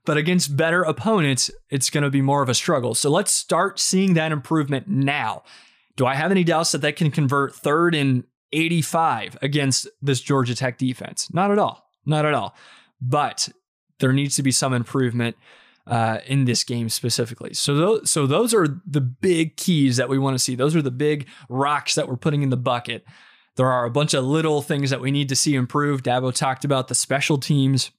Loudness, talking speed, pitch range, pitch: -21 LUFS, 210 wpm, 130-155 Hz, 140 Hz